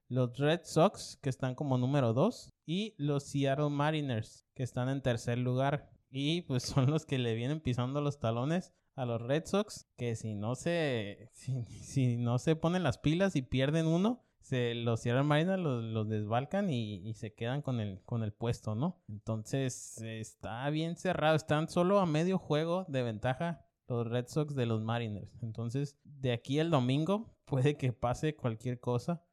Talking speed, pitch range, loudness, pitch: 180 wpm, 120-155 Hz, -34 LUFS, 130 Hz